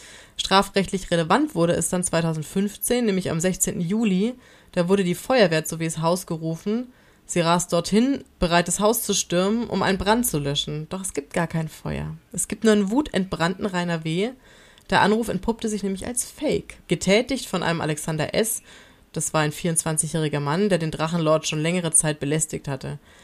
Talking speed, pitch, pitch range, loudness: 180 wpm, 175 Hz, 160-205 Hz, -23 LUFS